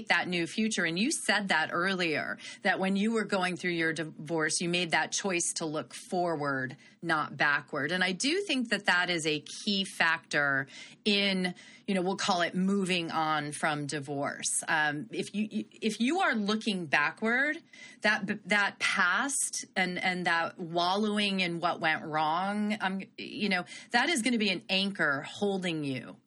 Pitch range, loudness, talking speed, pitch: 165-215 Hz, -29 LUFS, 175 wpm, 190 Hz